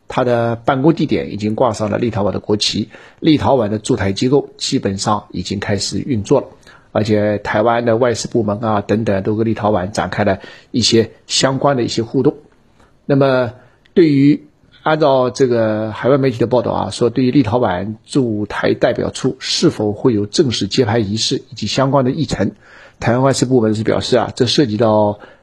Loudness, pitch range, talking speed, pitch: -16 LUFS, 105-135 Hz, 290 characters per minute, 115 Hz